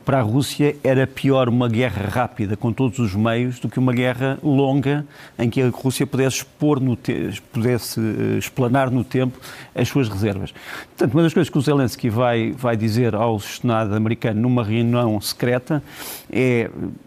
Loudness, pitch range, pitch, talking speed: -20 LUFS, 115-135 Hz, 125 Hz, 170 wpm